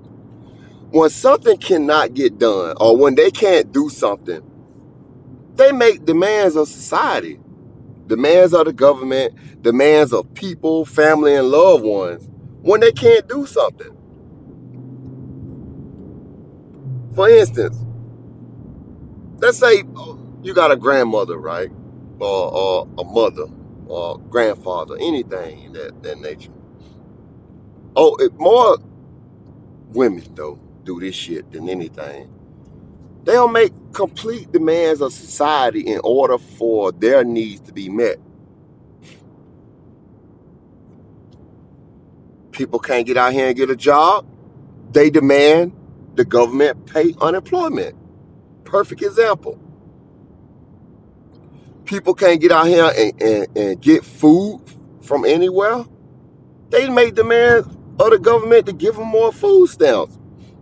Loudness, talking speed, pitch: -15 LUFS, 115 wpm, 200 Hz